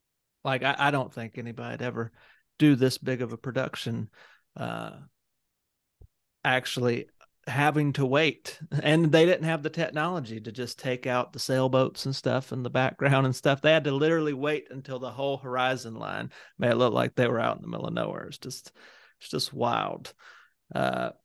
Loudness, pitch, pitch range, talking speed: -27 LUFS, 130 Hz, 125-150 Hz, 185 wpm